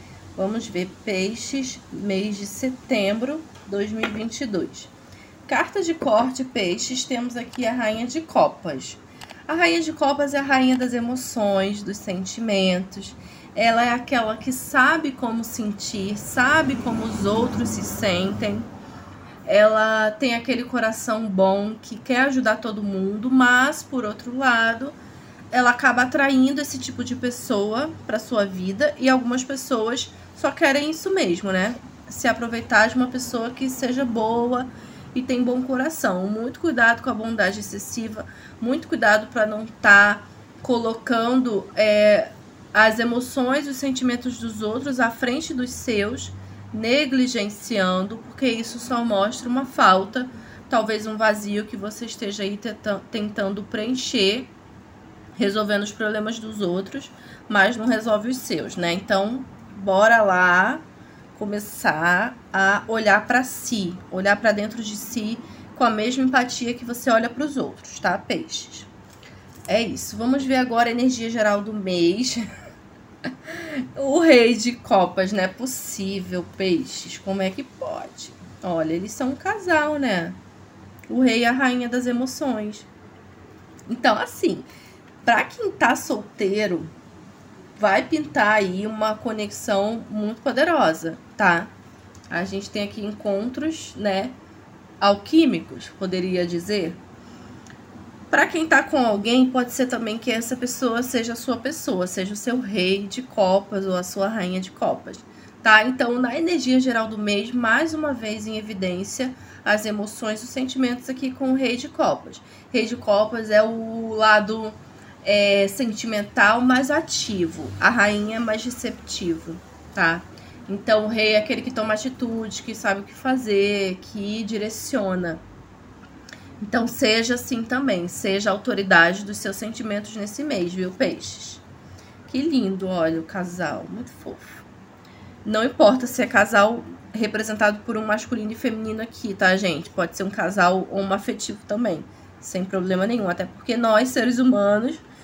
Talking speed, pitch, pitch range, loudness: 145 wpm, 225 Hz, 200-255 Hz, -22 LUFS